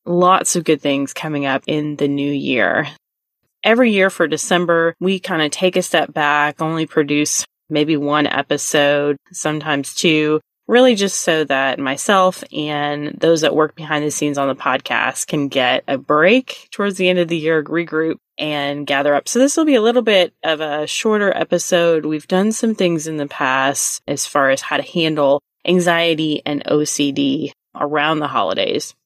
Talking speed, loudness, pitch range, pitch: 180 wpm, -17 LUFS, 145-180 Hz, 155 Hz